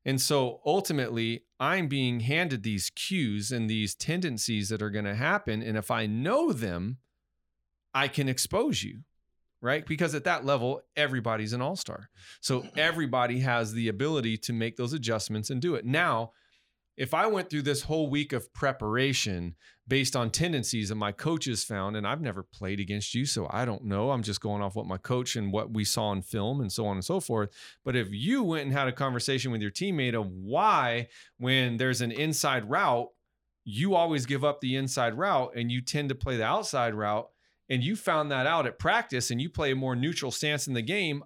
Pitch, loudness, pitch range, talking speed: 125 Hz, -29 LUFS, 110-140 Hz, 205 wpm